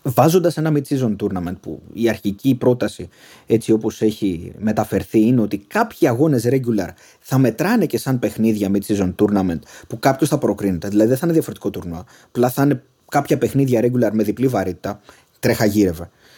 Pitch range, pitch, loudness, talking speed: 105-135 Hz, 115 Hz, -19 LUFS, 165 wpm